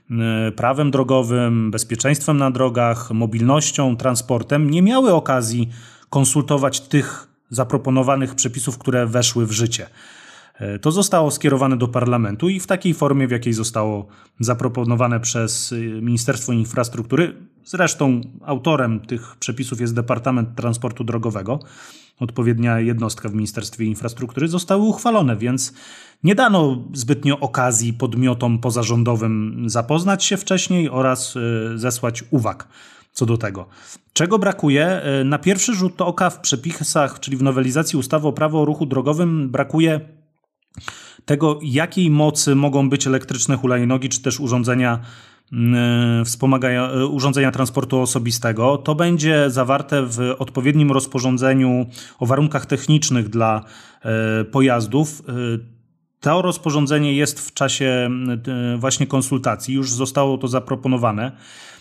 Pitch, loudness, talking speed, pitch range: 130 Hz, -19 LUFS, 115 wpm, 120-145 Hz